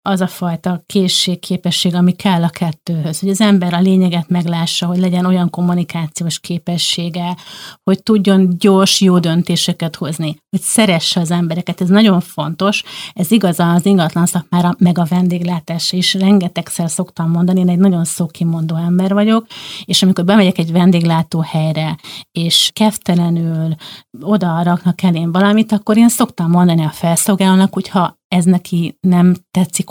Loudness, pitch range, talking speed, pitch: -14 LUFS, 170-190 Hz, 150 wpm, 180 Hz